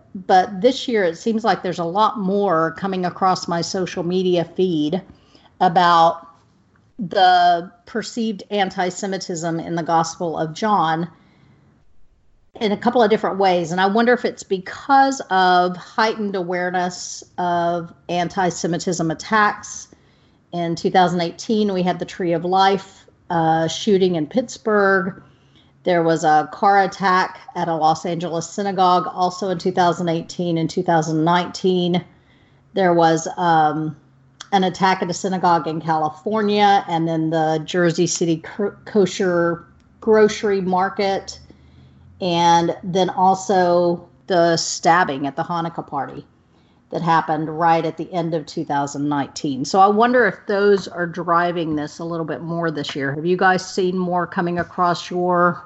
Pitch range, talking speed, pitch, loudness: 165-190 Hz, 140 wpm, 175 Hz, -19 LUFS